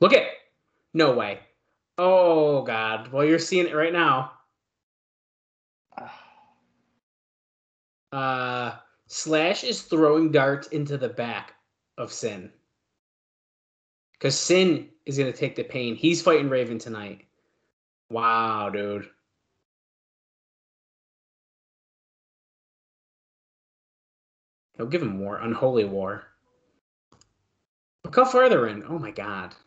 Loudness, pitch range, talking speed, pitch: -23 LUFS, 110-160 Hz, 100 wpm, 135 Hz